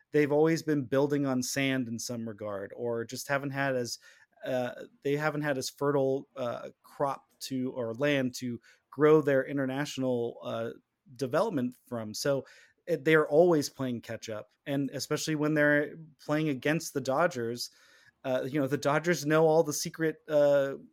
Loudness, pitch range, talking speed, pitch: -30 LUFS, 125-150 Hz, 160 wpm, 140 Hz